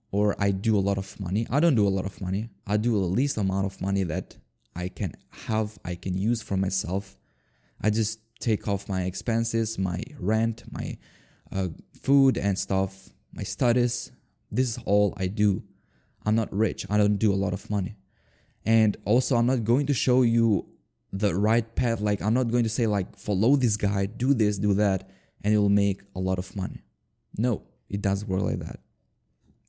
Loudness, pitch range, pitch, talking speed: -26 LUFS, 95-115 Hz, 105 Hz, 200 wpm